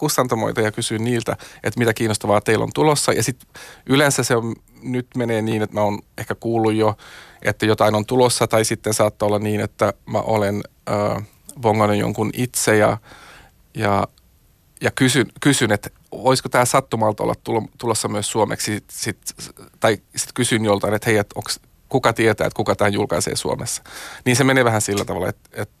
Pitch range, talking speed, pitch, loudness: 105-120 Hz, 180 wpm, 110 Hz, -20 LUFS